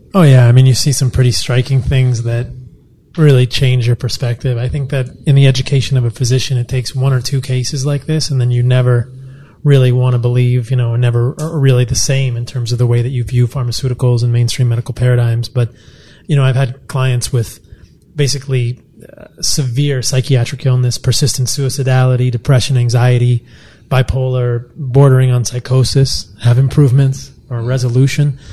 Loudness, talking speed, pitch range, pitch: -13 LUFS, 175 wpm, 120-135 Hz, 125 Hz